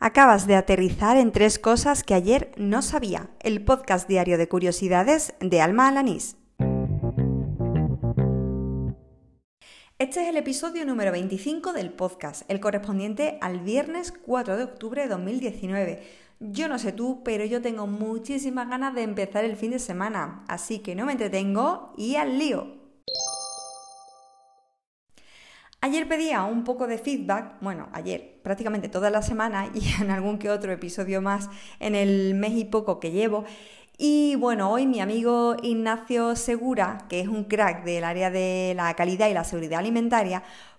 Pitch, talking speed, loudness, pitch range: 210 Hz, 155 wpm, -25 LUFS, 185-255 Hz